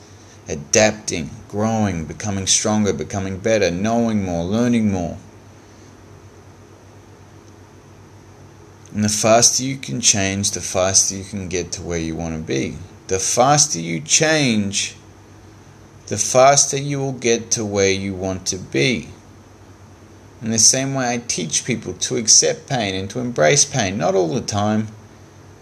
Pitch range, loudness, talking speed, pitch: 100-115 Hz, -18 LUFS, 140 wpm, 105 Hz